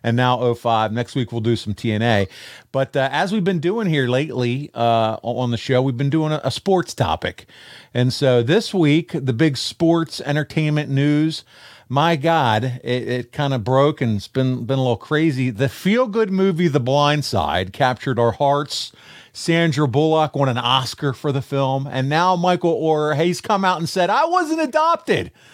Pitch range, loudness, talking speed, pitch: 125-165 Hz, -19 LUFS, 190 wpm, 140 Hz